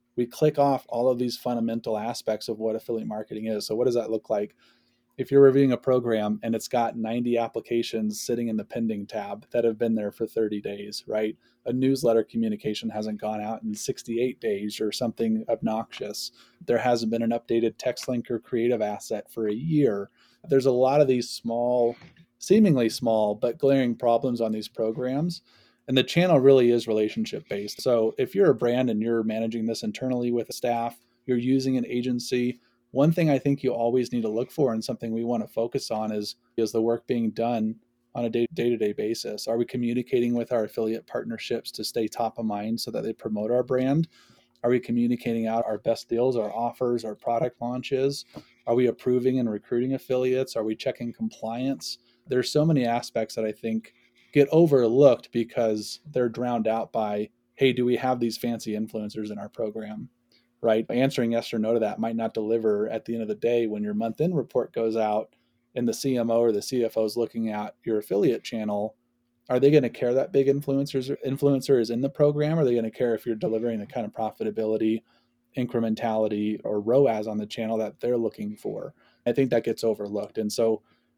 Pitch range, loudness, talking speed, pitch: 110-125 Hz, -26 LUFS, 200 wpm, 115 Hz